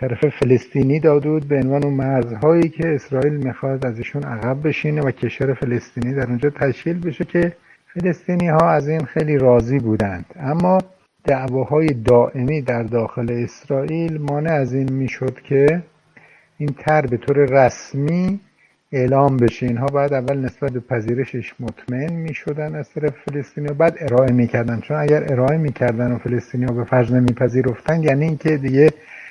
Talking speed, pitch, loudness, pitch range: 145 wpm, 140 Hz, -19 LUFS, 125-155 Hz